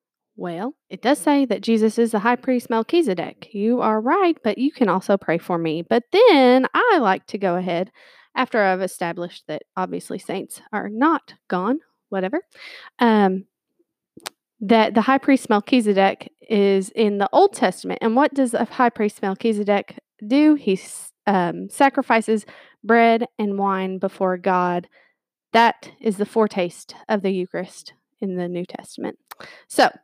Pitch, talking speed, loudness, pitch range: 220 Hz, 155 wpm, -20 LUFS, 195-265 Hz